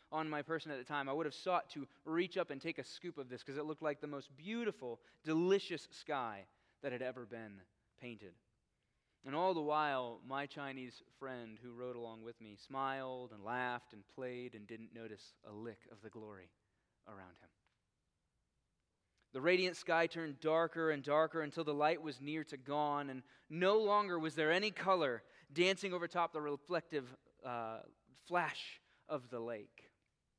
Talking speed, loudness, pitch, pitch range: 180 wpm, -40 LUFS, 140 Hz, 120-160 Hz